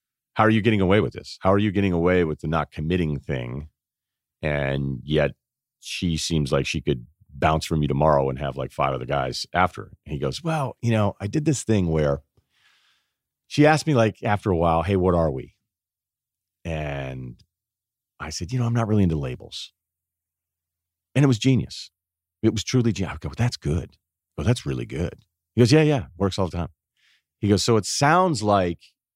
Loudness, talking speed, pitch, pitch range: -23 LUFS, 200 wpm, 90 Hz, 80-110 Hz